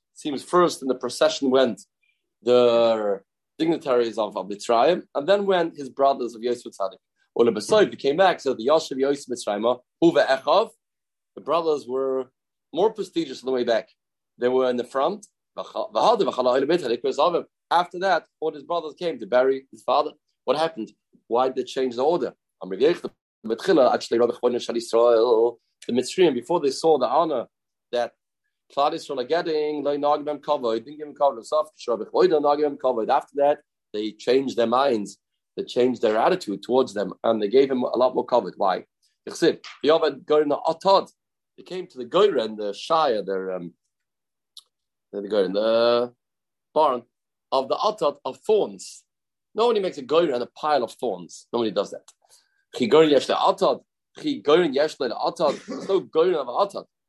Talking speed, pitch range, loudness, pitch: 170 wpm, 120-165 Hz, -23 LUFS, 135 Hz